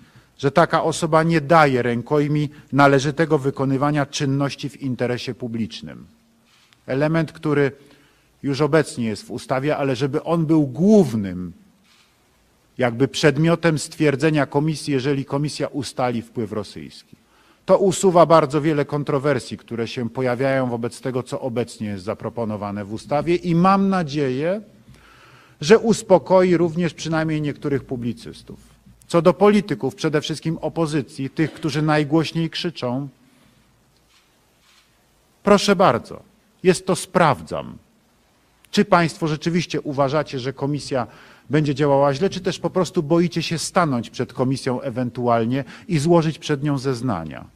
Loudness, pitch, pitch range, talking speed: -20 LUFS, 145 Hz, 130-165 Hz, 120 wpm